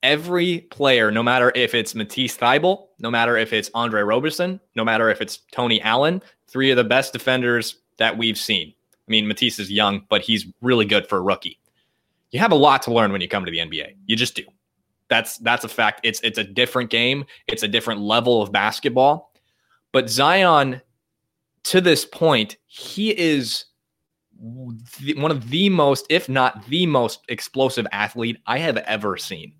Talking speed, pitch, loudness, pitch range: 185 wpm, 120 Hz, -19 LUFS, 115-140 Hz